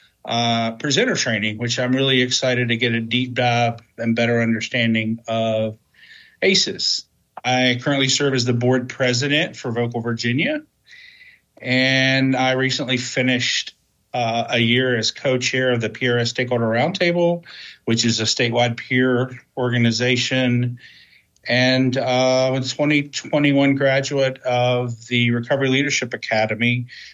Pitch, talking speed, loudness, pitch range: 125 Hz, 125 wpm, -19 LUFS, 120-130 Hz